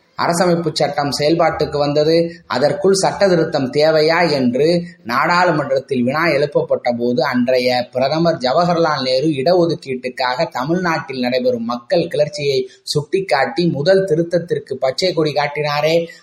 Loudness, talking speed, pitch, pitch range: -16 LUFS, 95 wpm, 155 Hz, 130-170 Hz